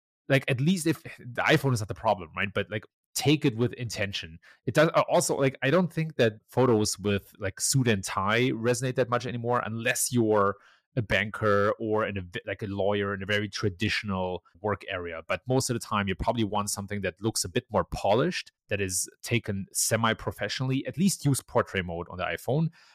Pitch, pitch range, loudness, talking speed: 110 Hz, 100-130 Hz, -28 LUFS, 205 wpm